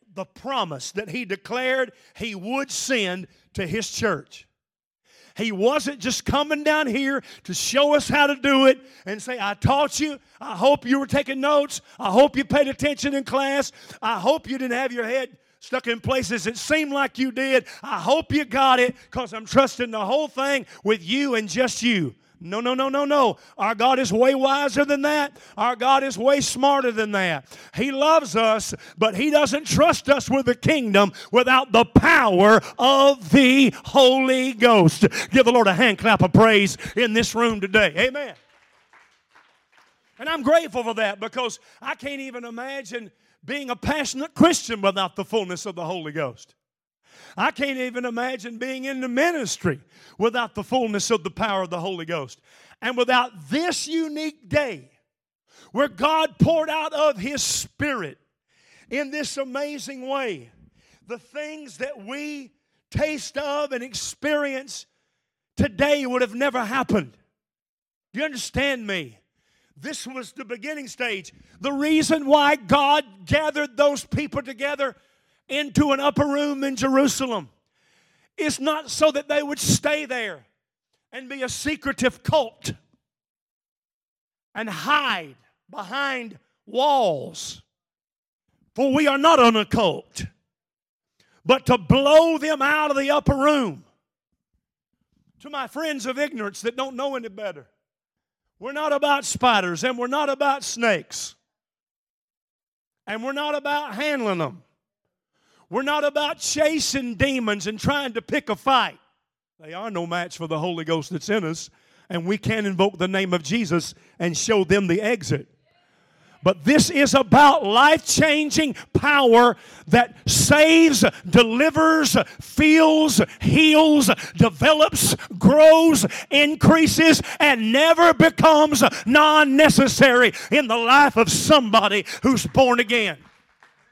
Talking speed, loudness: 150 wpm, -20 LUFS